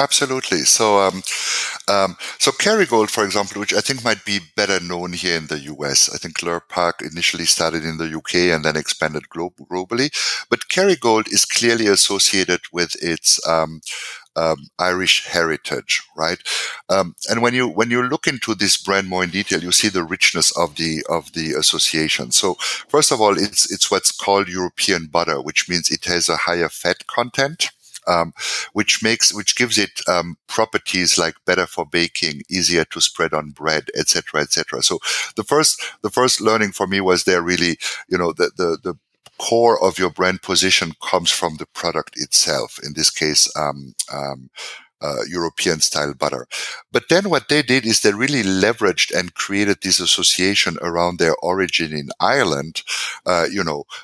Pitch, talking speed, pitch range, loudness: 90 Hz, 180 wpm, 80-105 Hz, -18 LUFS